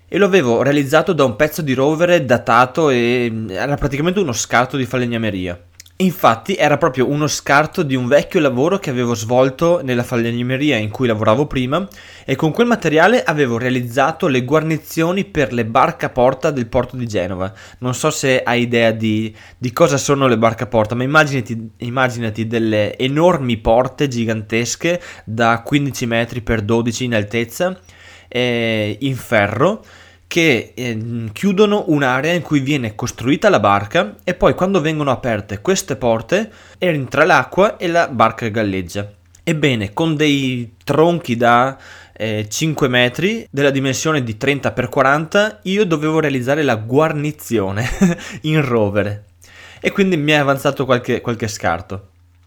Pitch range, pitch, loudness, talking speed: 115-155 Hz, 130 Hz, -16 LUFS, 150 wpm